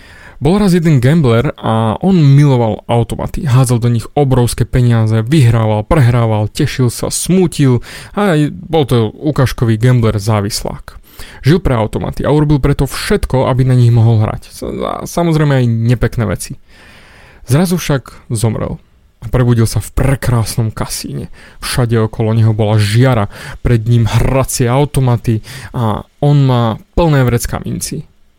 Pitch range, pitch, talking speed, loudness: 110-140 Hz, 125 Hz, 135 wpm, -13 LUFS